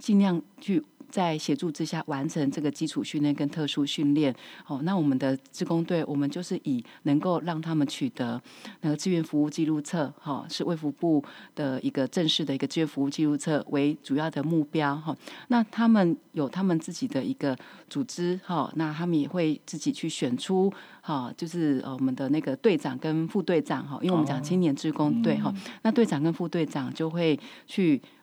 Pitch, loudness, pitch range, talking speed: 160 Hz, -28 LUFS, 145-180 Hz, 295 characters per minute